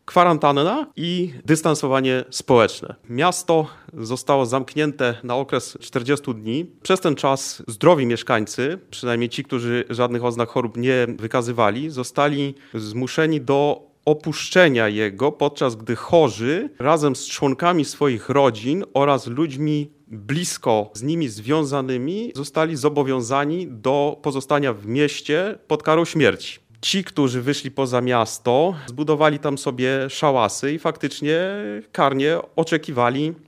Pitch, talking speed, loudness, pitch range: 140 Hz, 115 wpm, -21 LUFS, 125-155 Hz